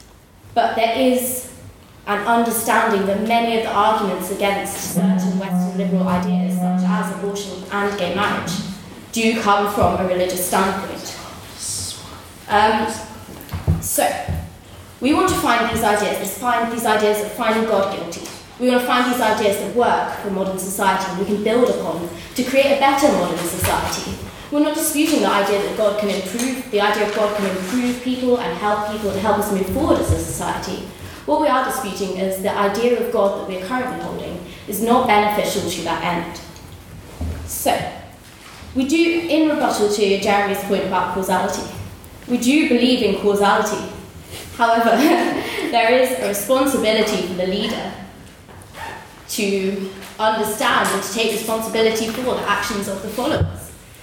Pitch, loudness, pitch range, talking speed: 205 Hz, -19 LUFS, 190-235 Hz, 160 wpm